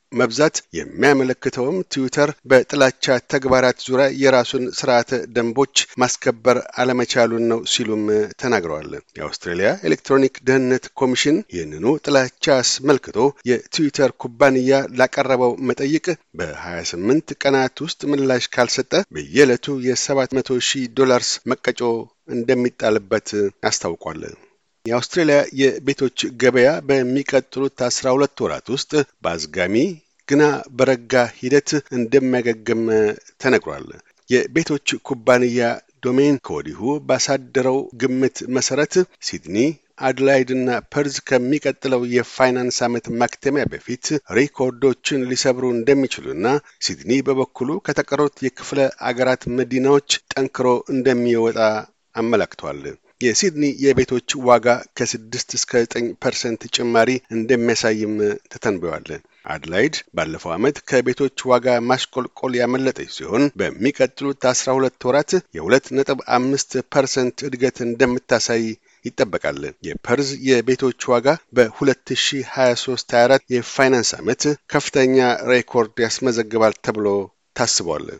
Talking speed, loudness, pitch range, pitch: 95 wpm, -19 LUFS, 120-135 Hz, 130 Hz